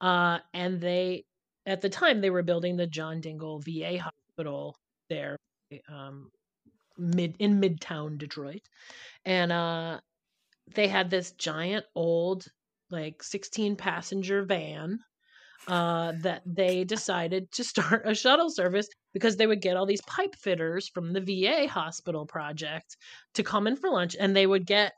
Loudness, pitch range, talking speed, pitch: -29 LUFS, 170-200 Hz, 150 wpm, 185 Hz